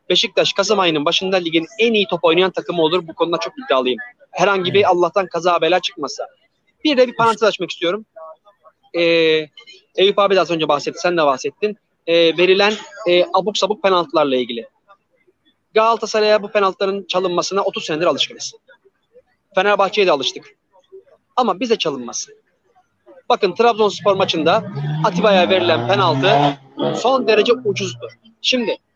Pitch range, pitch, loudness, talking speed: 170-225 Hz, 195 Hz, -17 LUFS, 135 wpm